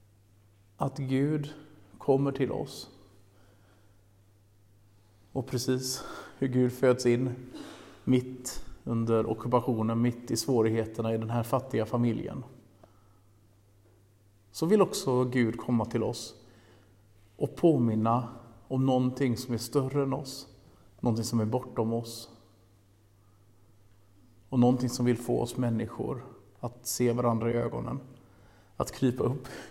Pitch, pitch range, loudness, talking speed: 115 Hz, 100-125 Hz, -30 LUFS, 115 wpm